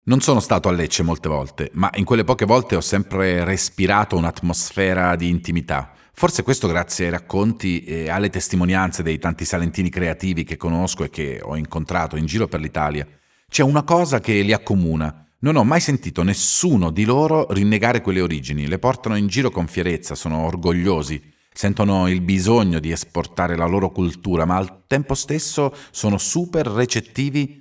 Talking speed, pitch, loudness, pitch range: 170 wpm, 95 Hz, -20 LUFS, 85-110 Hz